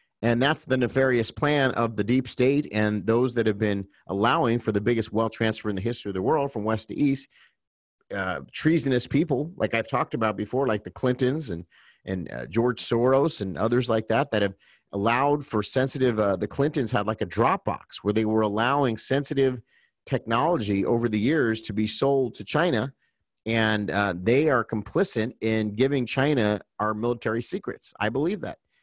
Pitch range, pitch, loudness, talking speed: 105-130 Hz, 115 Hz, -25 LUFS, 190 wpm